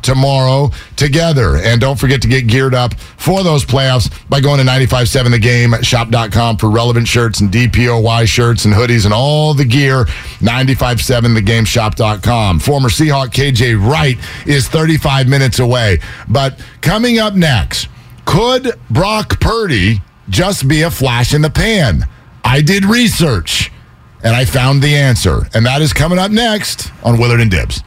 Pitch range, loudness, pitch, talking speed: 115-145 Hz, -11 LUFS, 125 Hz, 150 wpm